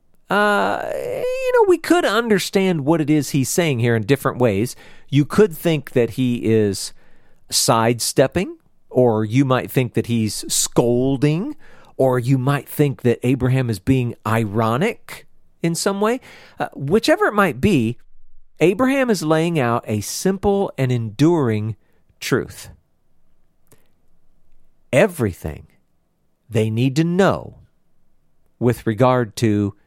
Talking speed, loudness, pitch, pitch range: 125 wpm, -19 LUFS, 130 Hz, 115-170 Hz